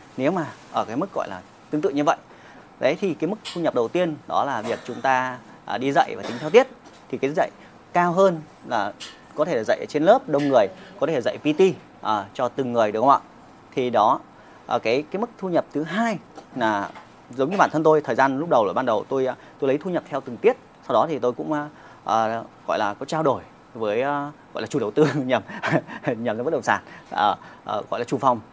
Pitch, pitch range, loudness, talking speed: 145 Hz, 130-175 Hz, -23 LUFS, 240 wpm